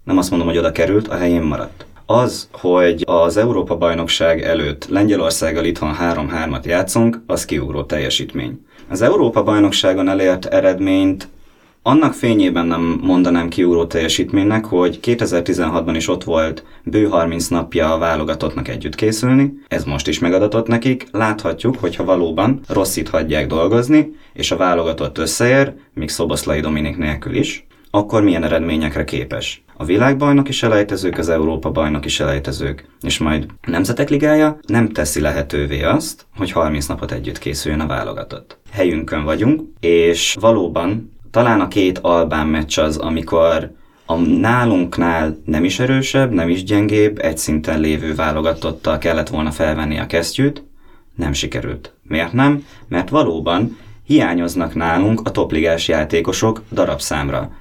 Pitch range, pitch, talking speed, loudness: 80-110 Hz, 85 Hz, 140 wpm, -16 LUFS